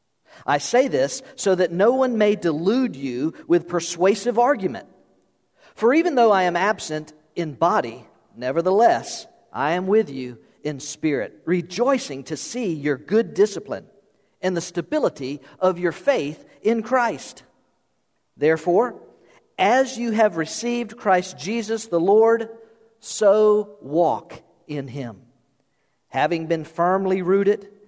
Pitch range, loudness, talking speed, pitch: 160-225 Hz, -21 LUFS, 125 wpm, 185 Hz